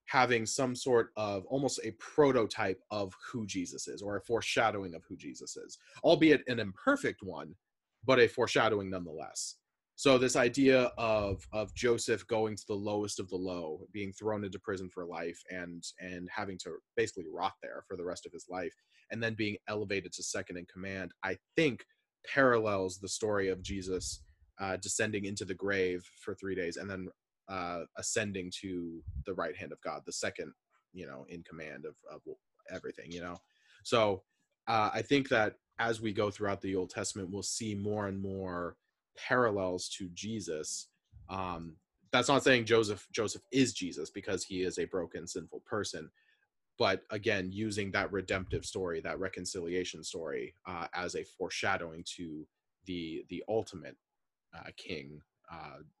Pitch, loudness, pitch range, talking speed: 100 Hz, -34 LUFS, 90-110 Hz, 170 wpm